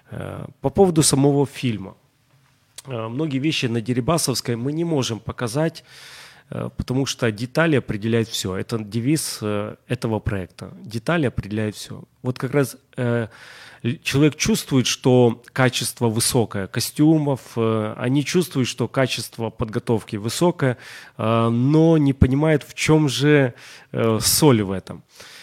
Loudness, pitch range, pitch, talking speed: -21 LUFS, 115-145 Hz, 125 Hz, 115 wpm